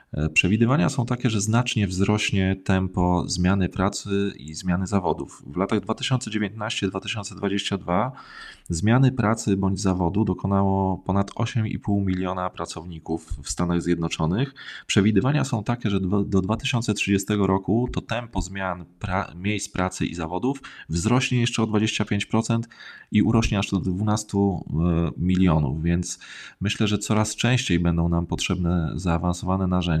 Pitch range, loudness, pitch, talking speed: 90-110 Hz, -24 LUFS, 100 Hz, 125 wpm